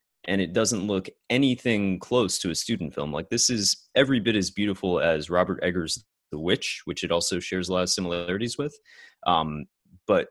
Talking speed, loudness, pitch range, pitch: 190 wpm, -25 LUFS, 90-115 Hz, 95 Hz